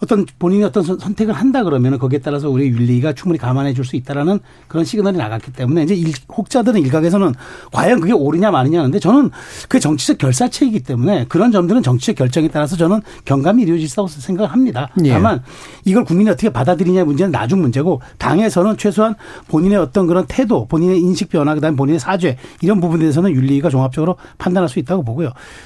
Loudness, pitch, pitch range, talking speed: -15 LUFS, 175 Hz, 145-205 Hz, 480 characters per minute